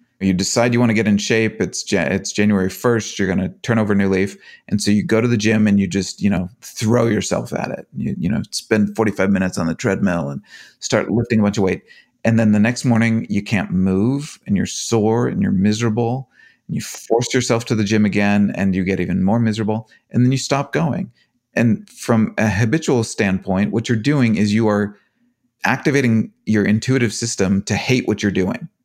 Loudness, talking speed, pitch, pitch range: -18 LUFS, 220 wpm, 110 Hz, 100-120 Hz